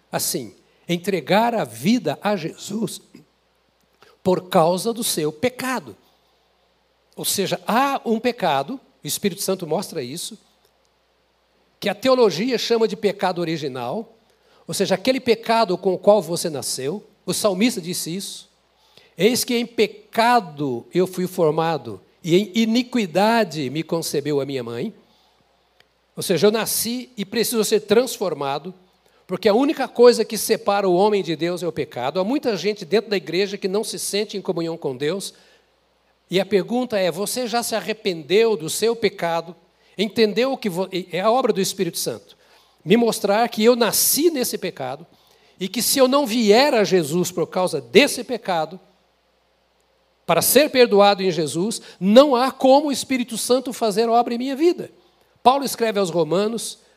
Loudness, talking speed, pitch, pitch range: -20 LUFS, 160 wpm, 205 Hz, 180-230 Hz